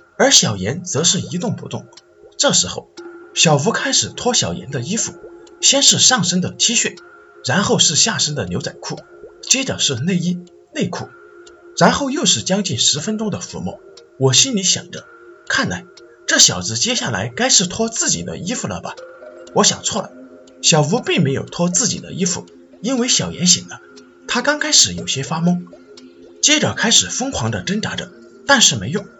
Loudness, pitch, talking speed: -15 LUFS, 195 Hz, 255 characters per minute